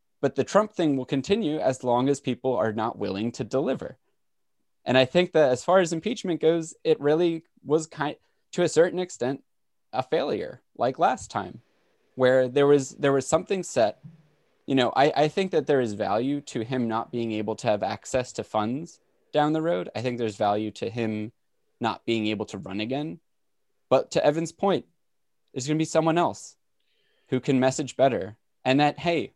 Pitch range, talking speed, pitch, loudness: 120-160 Hz, 190 wpm, 135 Hz, -25 LUFS